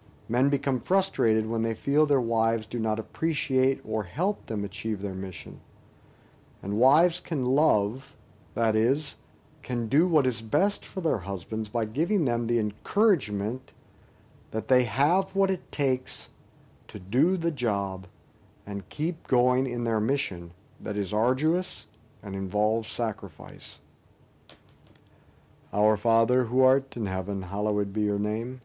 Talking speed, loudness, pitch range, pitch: 140 wpm, -27 LUFS, 105-140 Hz, 115 Hz